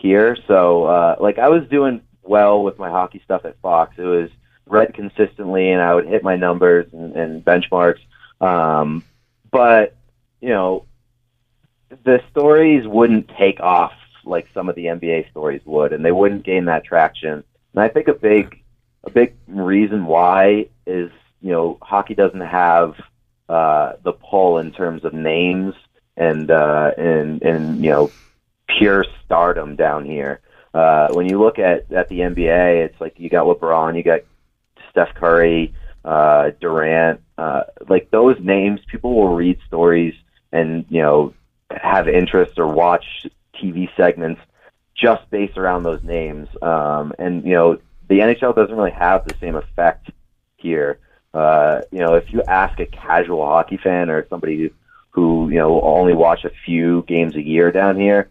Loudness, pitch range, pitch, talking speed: -16 LUFS, 85-105 Hz, 90 Hz, 165 wpm